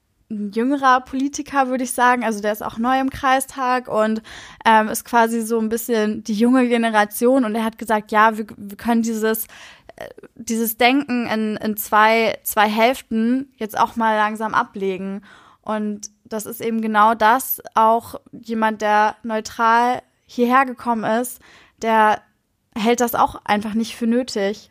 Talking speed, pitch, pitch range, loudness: 160 wpm, 225 Hz, 215-245 Hz, -19 LUFS